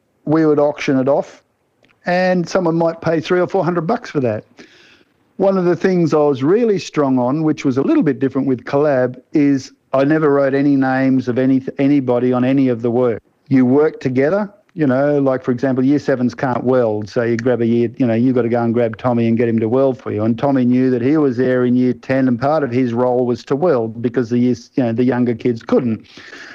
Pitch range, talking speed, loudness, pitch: 125-145 Hz, 240 wpm, -16 LUFS, 130 Hz